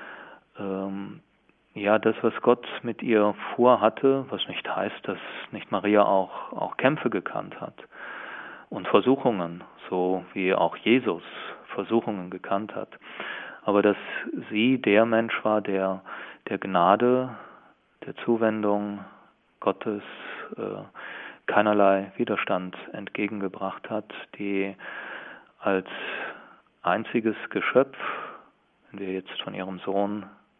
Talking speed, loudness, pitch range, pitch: 105 wpm, -26 LUFS, 95-110 Hz, 100 Hz